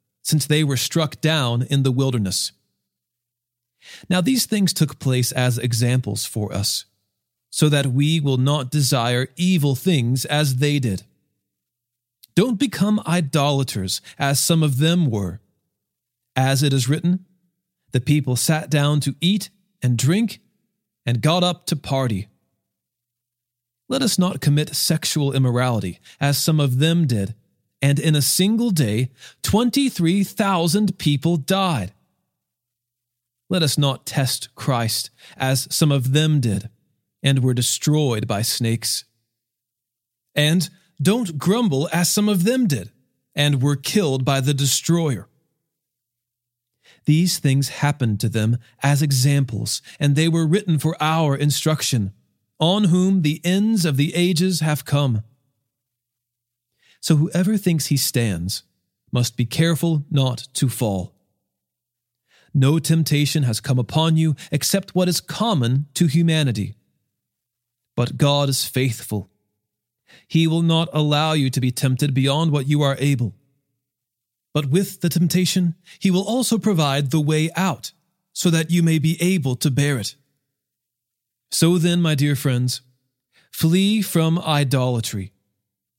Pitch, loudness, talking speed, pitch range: 140 Hz, -20 LUFS, 135 wpm, 120-165 Hz